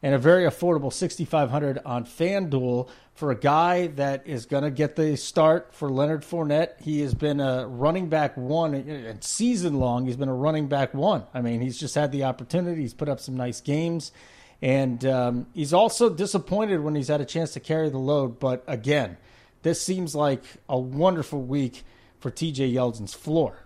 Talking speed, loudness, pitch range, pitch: 190 wpm, -25 LUFS, 130-160 Hz, 145 Hz